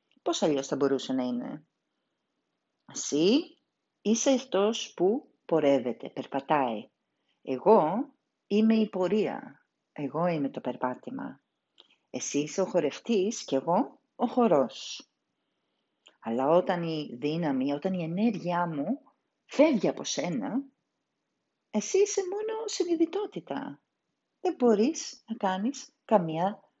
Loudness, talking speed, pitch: -29 LUFS, 105 wpm, 200 Hz